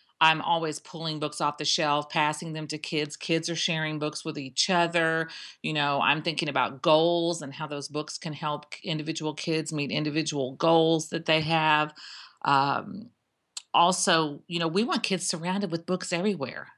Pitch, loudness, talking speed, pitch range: 160 Hz, -27 LUFS, 175 wpm, 150-170 Hz